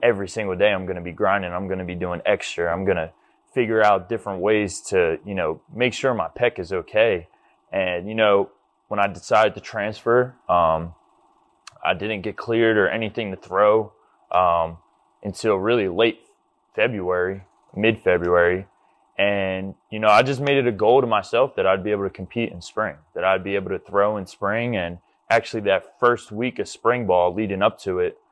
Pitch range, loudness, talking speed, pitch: 90-110 Hz, -22 LUFS, 195 wpm, 100 Hz